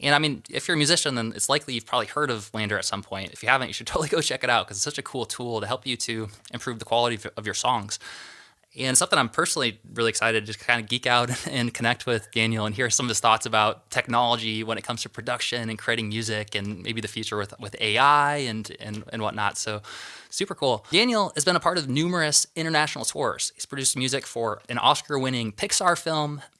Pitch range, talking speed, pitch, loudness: 110-140 Hz, 240 wpm, 120 Hz, -24 LUFS